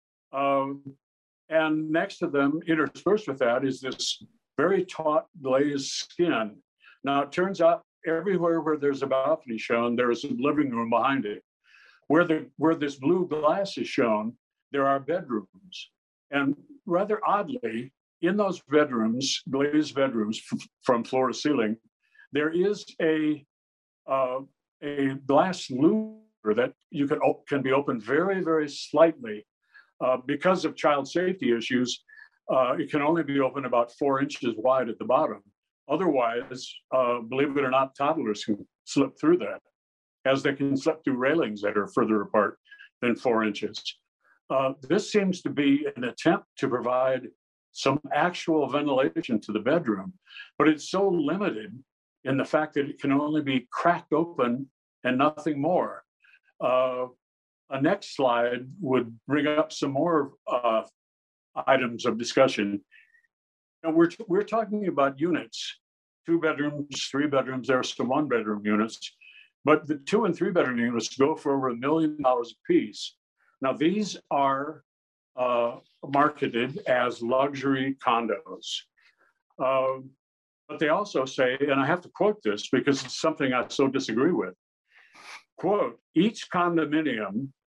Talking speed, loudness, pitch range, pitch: 150 wpm, -26 LUFS, 125-160 Hz, 140 Hz